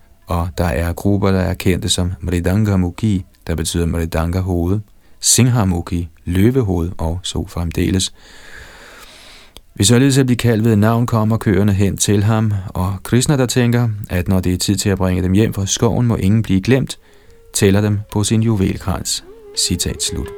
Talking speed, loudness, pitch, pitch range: 170 wpm, -16 LUFS, 95 Hz, 90-110 Hz